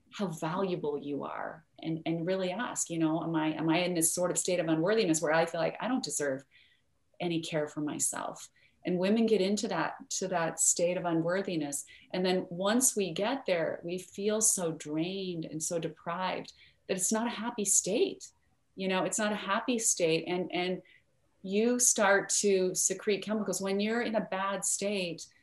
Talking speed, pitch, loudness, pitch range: 190 wpm, 185 Hz, -30 LUFS, 165-200 Hz